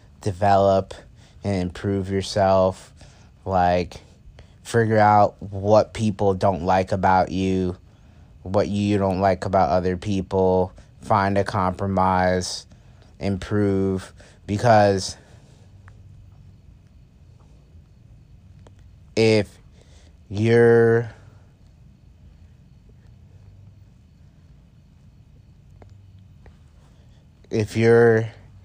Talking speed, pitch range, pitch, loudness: 60 wpm, 95-105 Hz, 100 Hz, -20 LUFS